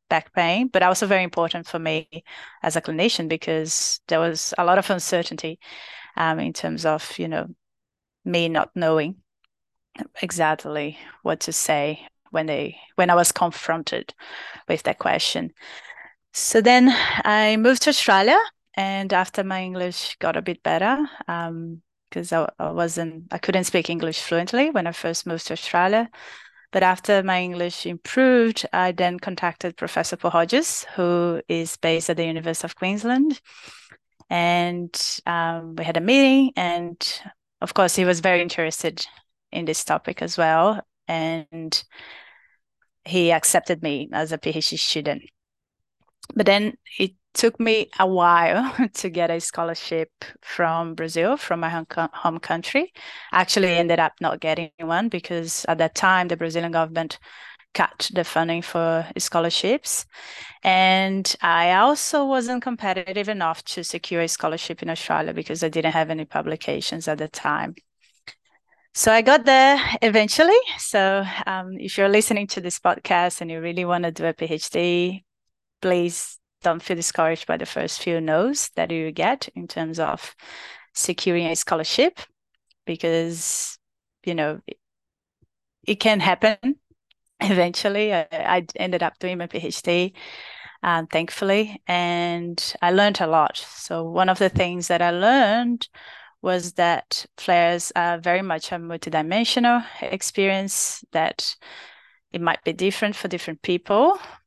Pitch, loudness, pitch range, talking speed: 175 Hz, -22 LUFS, 165-200 Hz, 150 wpm